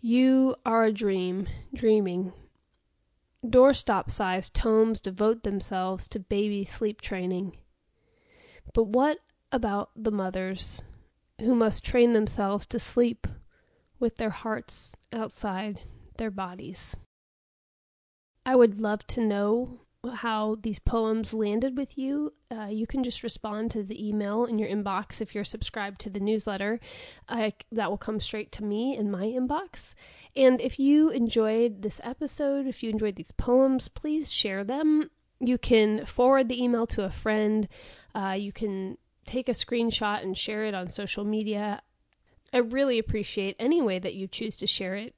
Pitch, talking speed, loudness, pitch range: 220 Hz, 150 wpm, -28 LUFS, 205-245 Hz